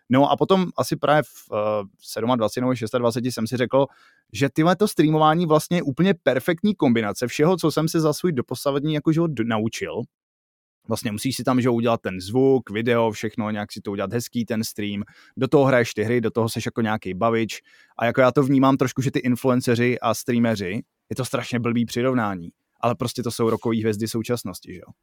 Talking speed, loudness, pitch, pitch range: 200 wpm, -22 LUFS, 120 Hz, 115-140 Hz